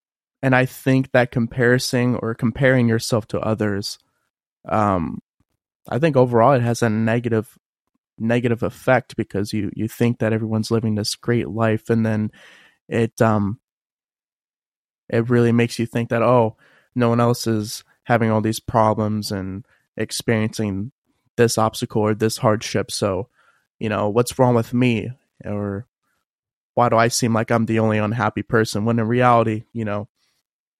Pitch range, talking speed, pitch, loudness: 110-120 Hz, 155 wpm, 115 Hz, -20 LUFS